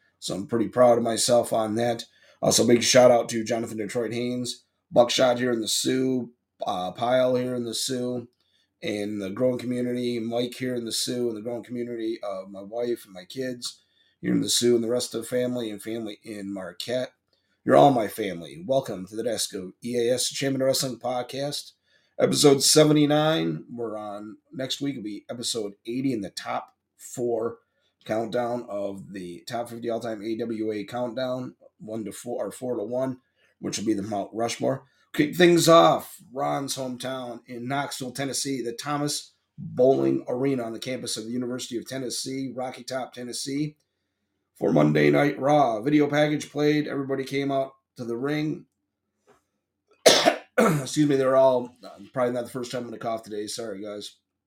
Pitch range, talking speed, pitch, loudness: 110-130 Hz, 175 wpm, 120 Hz, -25 LUFS